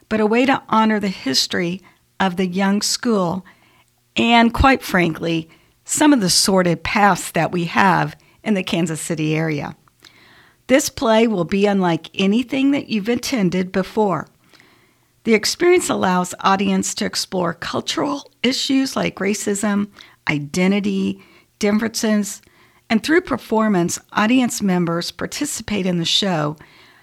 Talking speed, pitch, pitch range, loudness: 130 wpm, 200 Hz, 175-225 Hz, -18 LUFS